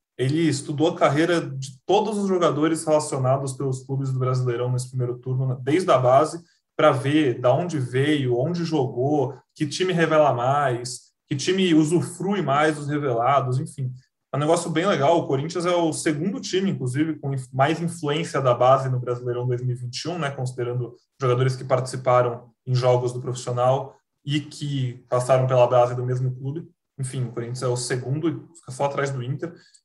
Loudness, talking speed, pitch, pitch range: -23 LUFS, 175 wpm, 135 Hz, 125-155 Hz